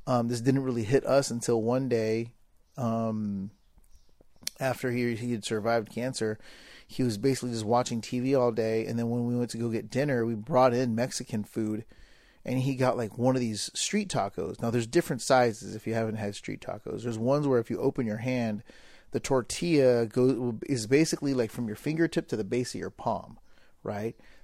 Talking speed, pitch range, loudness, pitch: 200 wpm, 115-130 Hz, -29 LUFS, 120 Hz